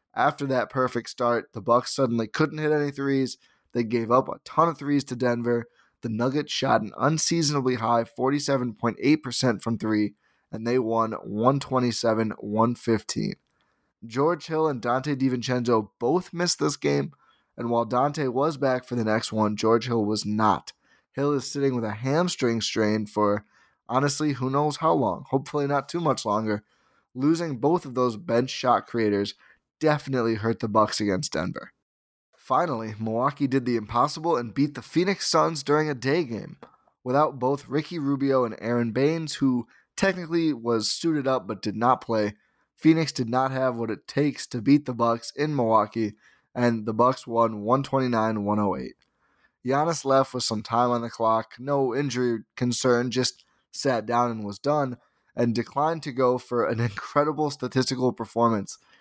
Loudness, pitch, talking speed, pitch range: -25 LUFS, 125 Hz, 165 wpm, 115-140 Hz